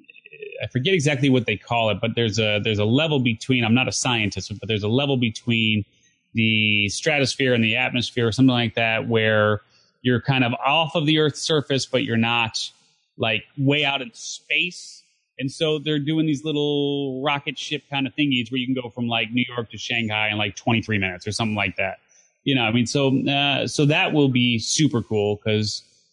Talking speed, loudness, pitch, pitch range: 210 wpm, -21 LUFS, 125 Hz, 110-140 Hz